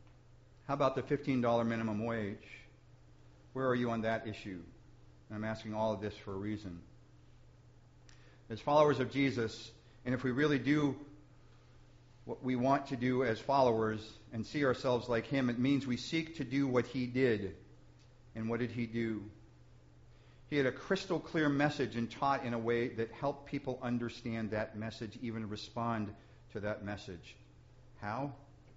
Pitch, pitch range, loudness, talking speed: 120 Hz, 110-135 Hz, -35 LUFS, 165 wpm